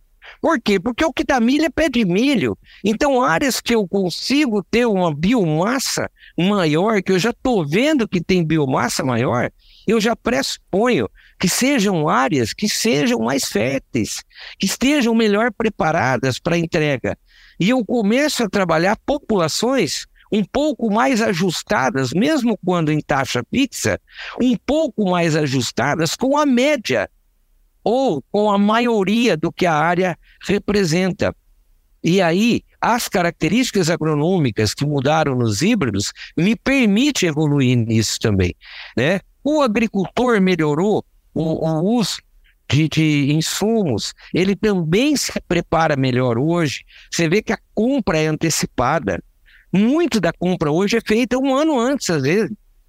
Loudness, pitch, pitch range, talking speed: -18 LUFS, 195 Hz, 160-235 Hz, 140 wpm